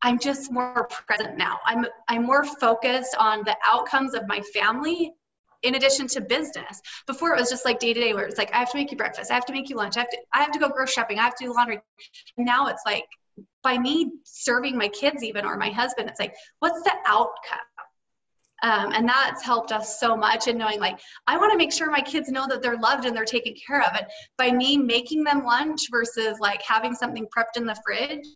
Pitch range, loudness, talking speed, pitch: 230-280 Hz, -24 LUFS, 235 wpm, 245 Hz